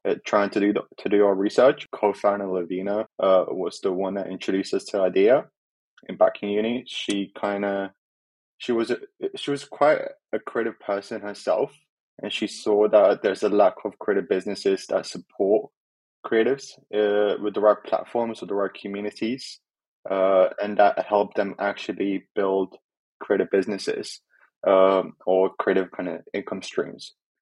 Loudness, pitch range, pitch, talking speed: -24 LUFS, 95-105 Hz, 100 Hz, 160 wpm